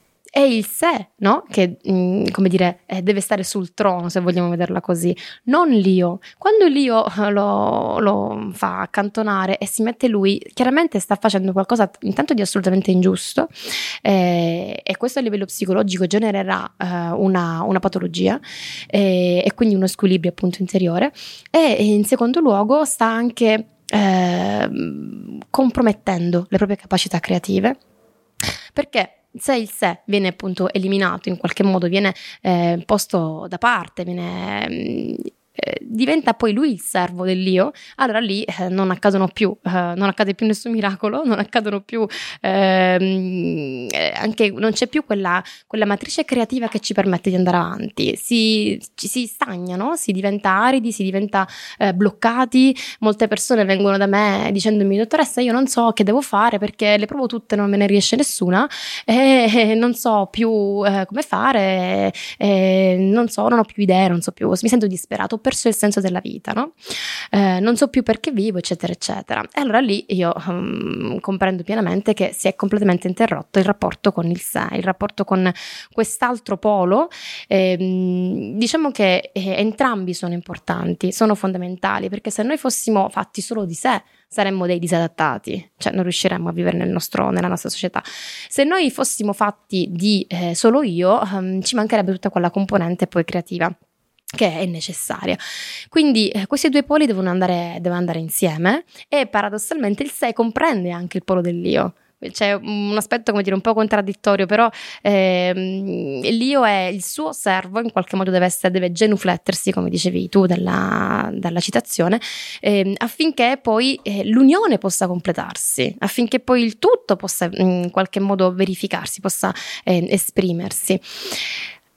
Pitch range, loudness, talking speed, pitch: 185-225 Hz, -19 LUFS, 160 wpm, 200 Hz